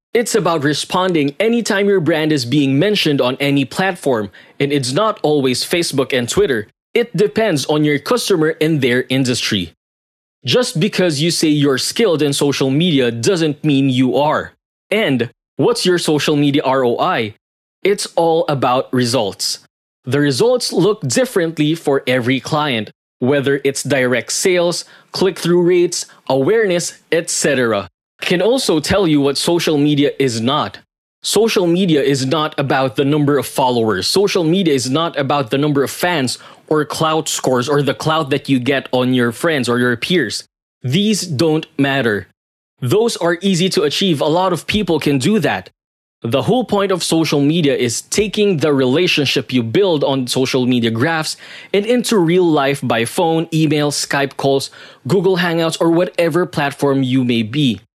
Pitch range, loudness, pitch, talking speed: 135-175 Hz, -16 LUFS, 150 Hz, 160 wpm